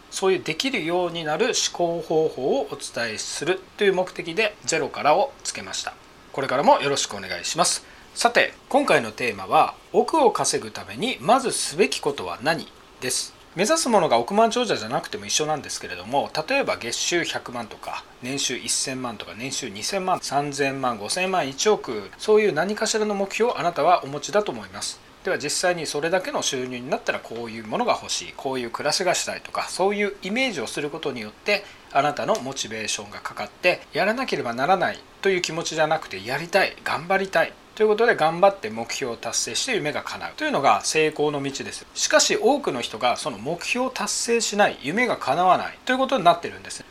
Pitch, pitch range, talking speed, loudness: 175 Hz, 140-210 Hz, 375 characters per minute, -23 LUFS